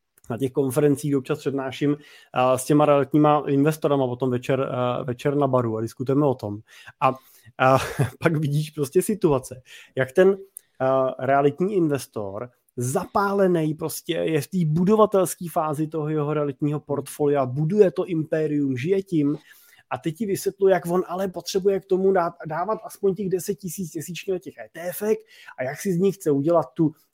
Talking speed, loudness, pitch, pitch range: 160 wpm, -23 LUFS, 150 Hz, 135-180 Hz